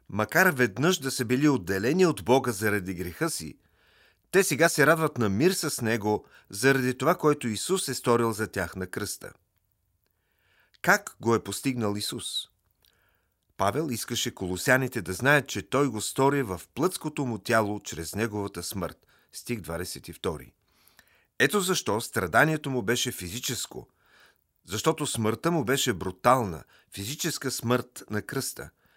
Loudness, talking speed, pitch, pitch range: -27 LUFS, 140 wpm, 115 Hz, 95-140 Hz